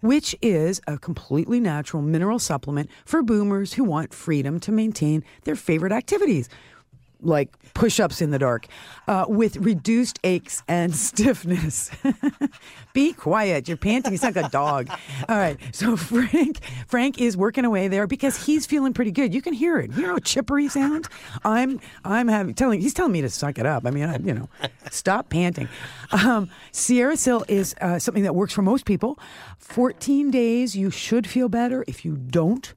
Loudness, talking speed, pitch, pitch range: -23 LUFS, 180 wpm, 210 Hz, 165-250 Hz